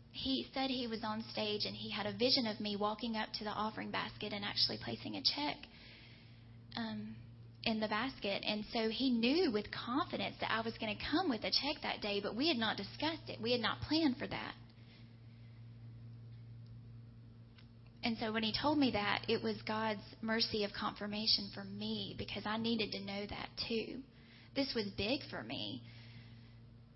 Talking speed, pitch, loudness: 185 wpm, 205 Hz, -37 LUFS